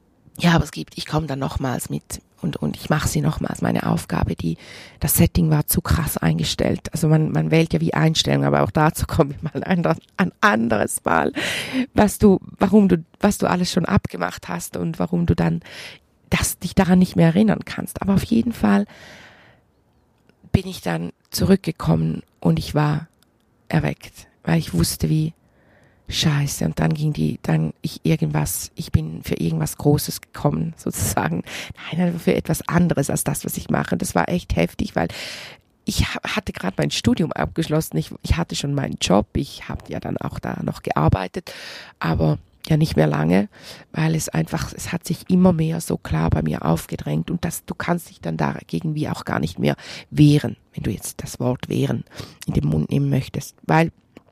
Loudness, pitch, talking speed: -21 LUFS, 140 Hz, 190 wpm